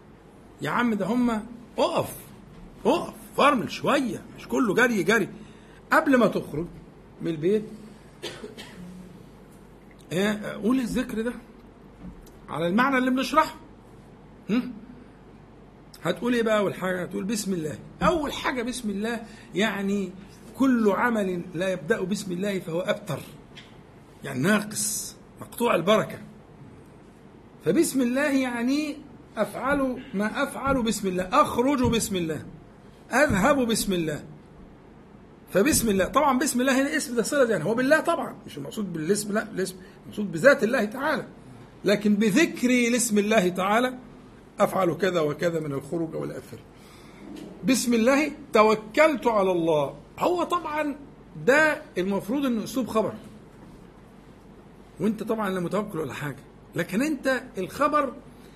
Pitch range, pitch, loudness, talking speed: 190-255 Hz, 220 Hz, -25 LUFS, 120 wpm